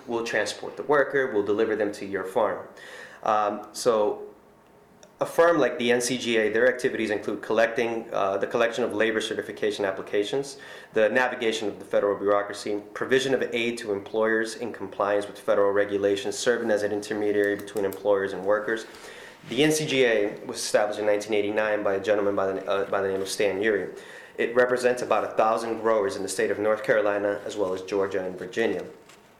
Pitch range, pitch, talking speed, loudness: 100-130 Hz, 110 Hz, 180 wpm, -25 LUFS